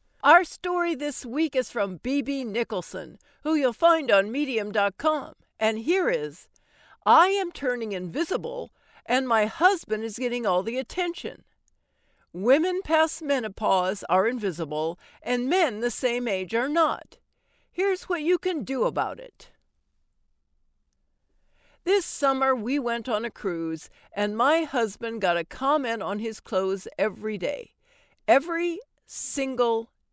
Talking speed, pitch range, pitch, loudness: 135 wpm, 205-315 Hz, 245 Hz, -25 LUFS